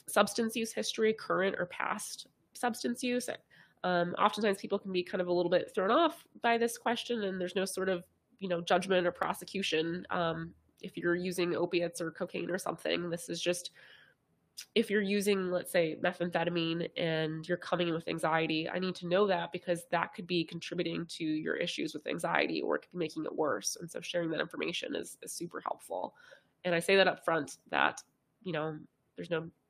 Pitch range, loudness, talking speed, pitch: 170-200 Hz, -33 LUFS, 200 wpm, 180 Hz